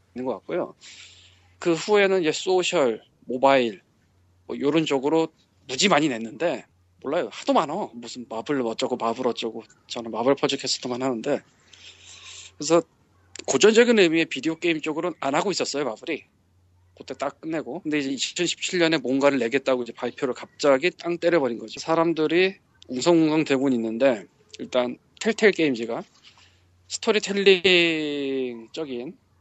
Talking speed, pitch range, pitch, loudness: 310 characters per minute, 115-165 Hz, 135 Hz, -23 LUFS